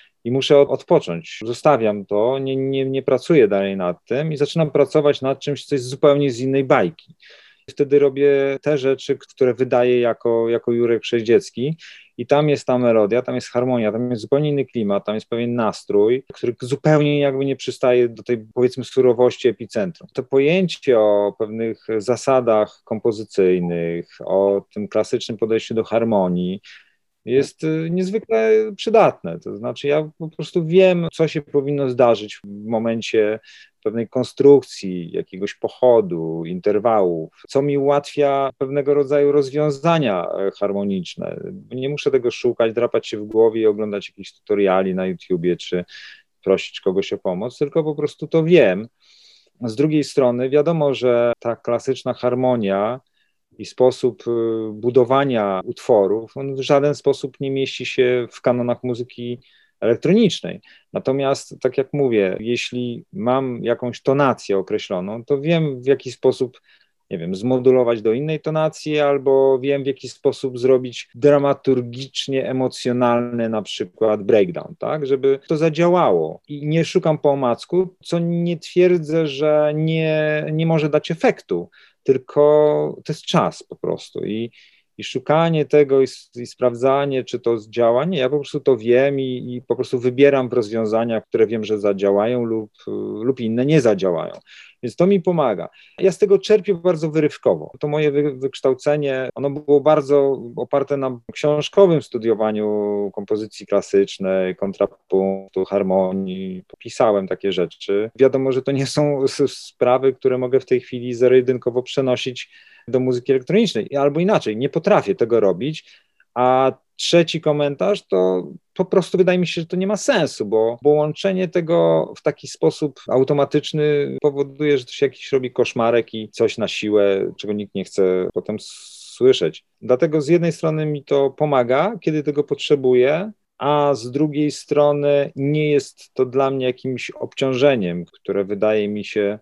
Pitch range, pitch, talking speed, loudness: 115-150 Hz, 135 Hz, 150 wpm, -19 LUFS